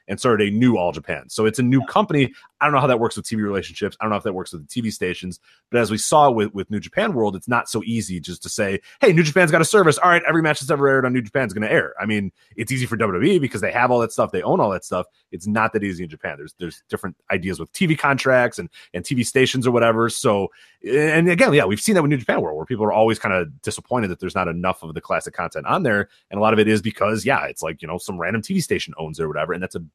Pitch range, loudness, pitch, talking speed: 100-135 Hz, -20 LUFS, 115 Hz, 305 wpm